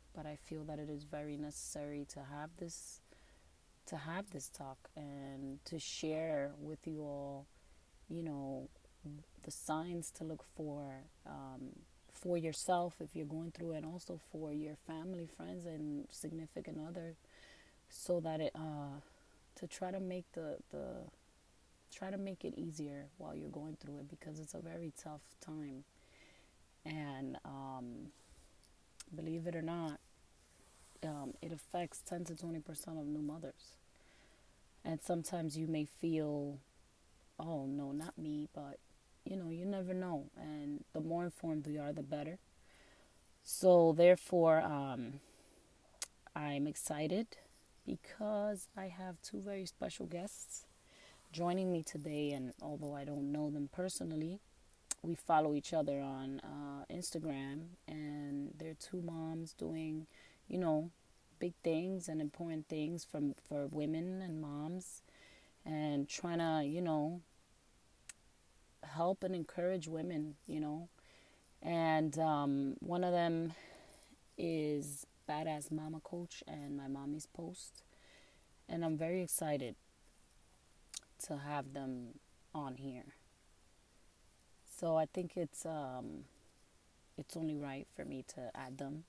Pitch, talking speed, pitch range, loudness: 155 Hz, 135 wpm, 145-170 Hz, -41 LUFS